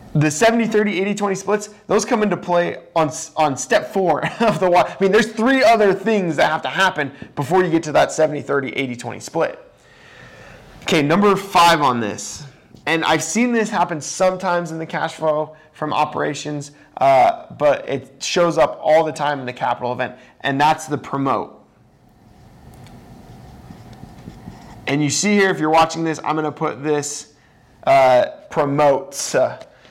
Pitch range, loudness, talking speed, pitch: 150-200 Hz, -18 LUFS, 175 wpm, 160 Hz